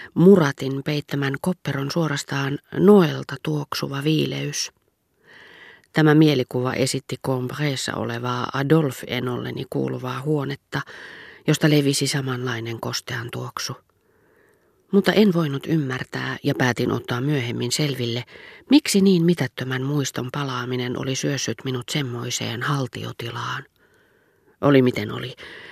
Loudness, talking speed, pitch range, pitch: -22 LUFS, 100 wpm, 125-155 Hz, 140 Hz